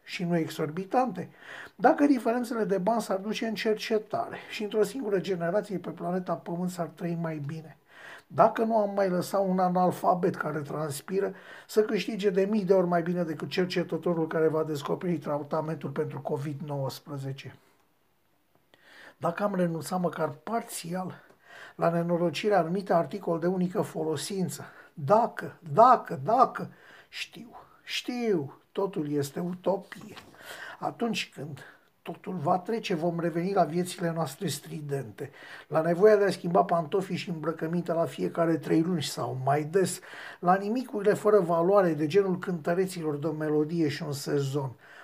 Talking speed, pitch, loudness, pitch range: 140 wpm, 175 Hz, -28 LUFS, 160-200 Hz